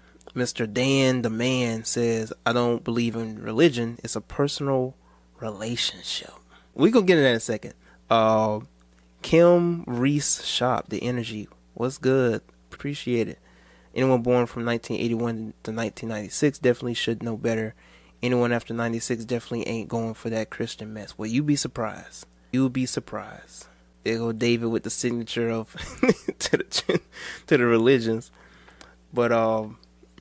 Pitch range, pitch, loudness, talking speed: 110-125 Hz, 115 Hz, -25 LUFS, 145 wpm